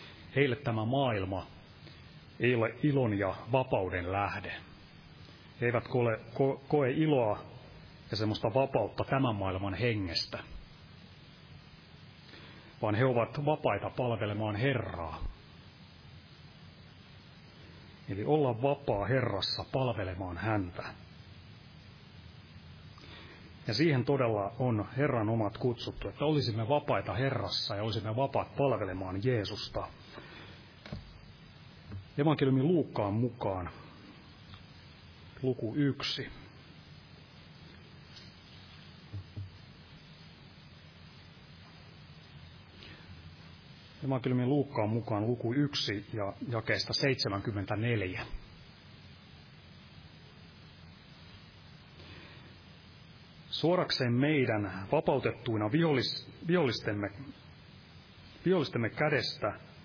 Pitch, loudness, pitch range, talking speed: 115 Hz, -32 LUFS, 100-135 Hz, 65 wpm